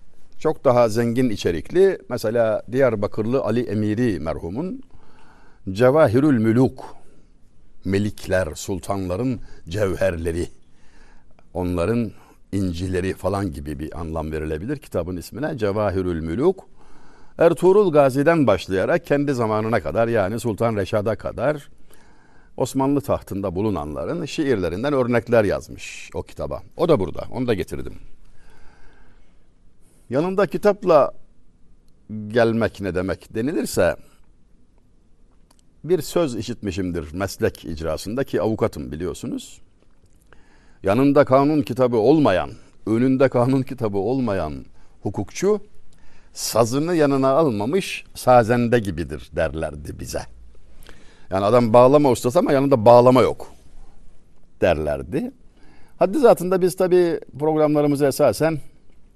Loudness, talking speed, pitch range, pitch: -20 LUFS, 95 wpm, 95-140 Hz, 115 Hz